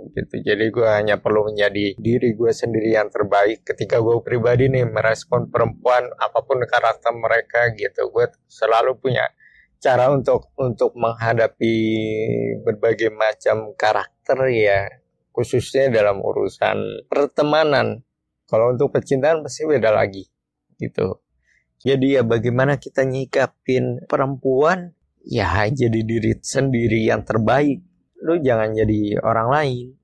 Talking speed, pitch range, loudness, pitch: 120 wpm, 110-135 Hz, -19 LUFS, 120 Hz